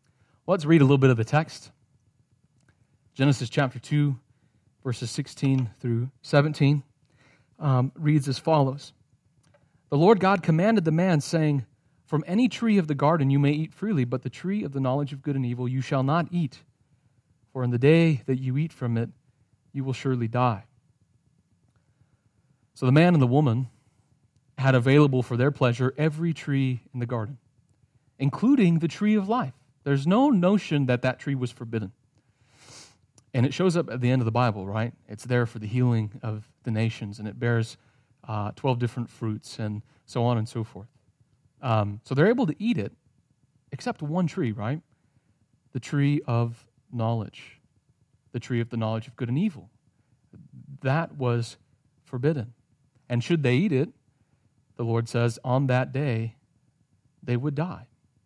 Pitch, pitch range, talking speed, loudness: 130 Hz, 120-145 Hz, 170 wpm, -25 LUFS